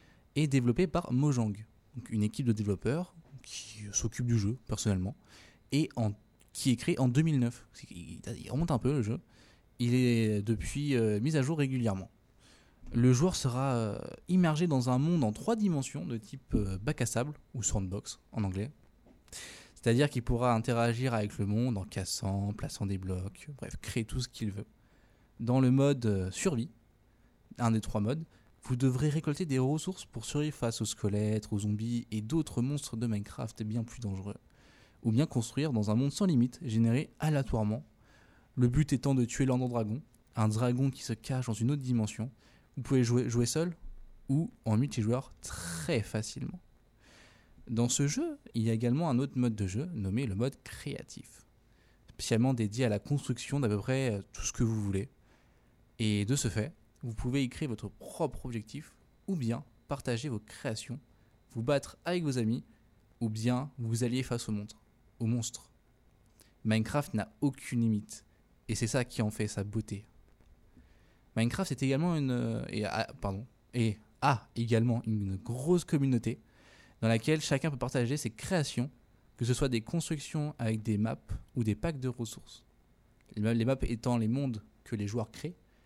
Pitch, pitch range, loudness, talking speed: 120 Hz, 110-135 Hz, -32 LUFS, 175 wpm